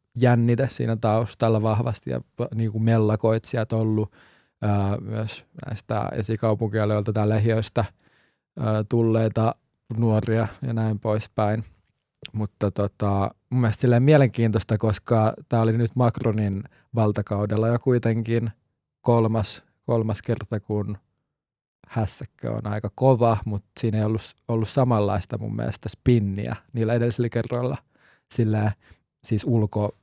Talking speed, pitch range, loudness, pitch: 110 wpm, 105-115 Hz, -24 LUFS, 110 Hz